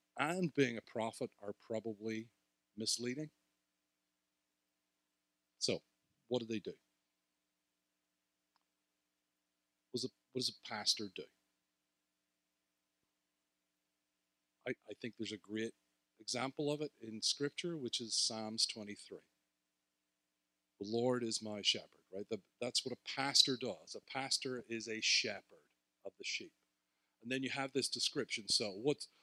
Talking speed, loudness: 130 wpm, -38 LUFS